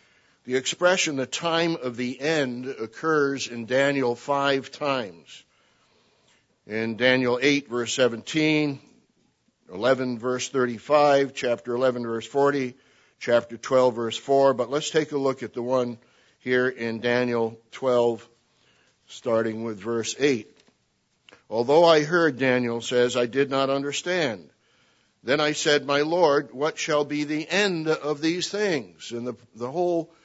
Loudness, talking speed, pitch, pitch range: -24 LUFS, 140 wpm, 130 Hz, 120-150 Hz